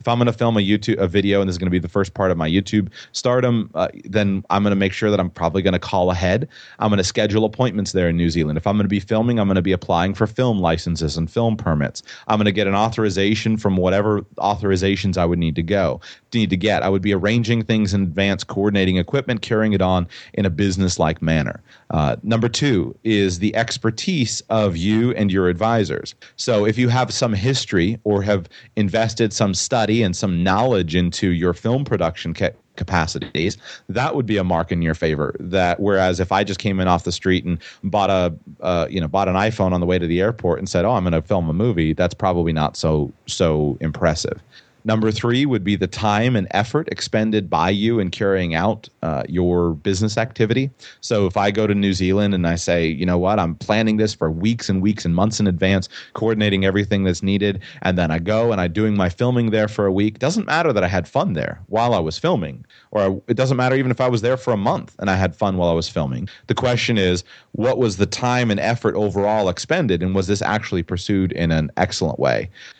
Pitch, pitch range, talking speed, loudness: 100 Hz, 90-110 Hz, 235 wpm, -19 LUFS